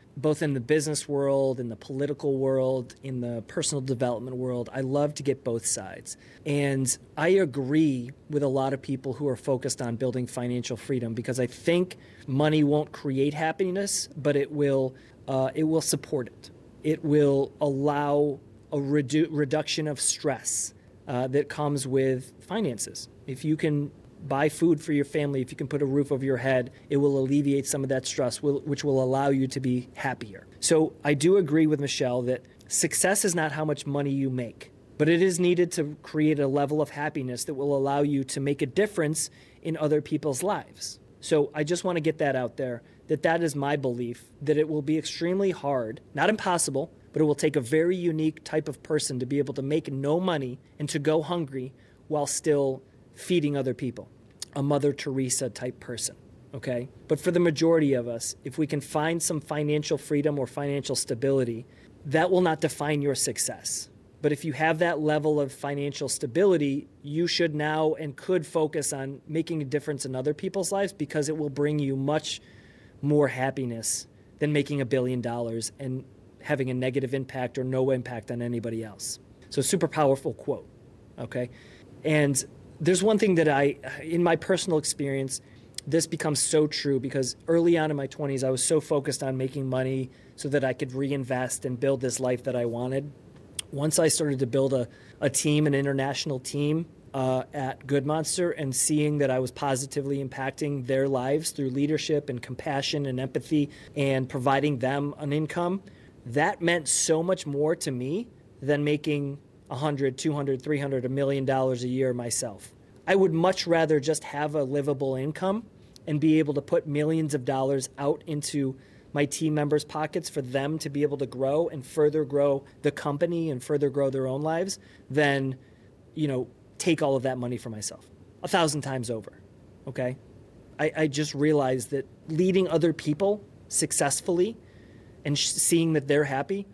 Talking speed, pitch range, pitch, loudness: 185 wpm, 130-155 Hz, 140 Hz, -27 LUFS